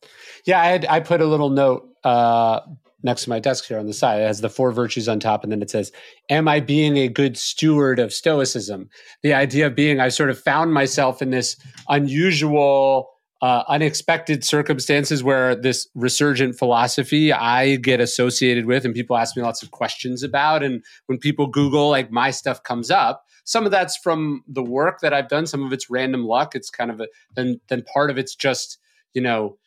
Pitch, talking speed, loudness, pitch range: 135 Hz, 205 wpm, -19 LUFS, 125-150 Hz